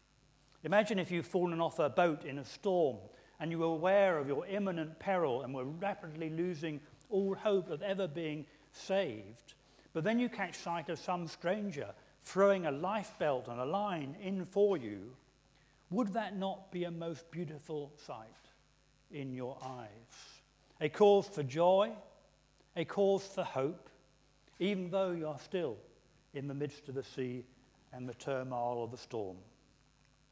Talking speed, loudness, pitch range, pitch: 160 wpm, -36 LUFS, 135-190 Hz, 155 Hz